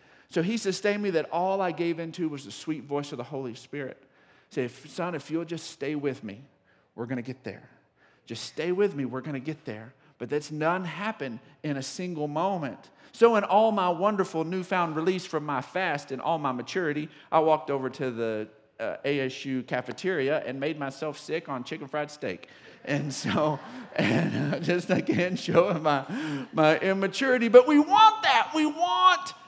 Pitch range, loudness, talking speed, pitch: 135-185 Hz, -27 LUFS, 190 wpm, 155 Hz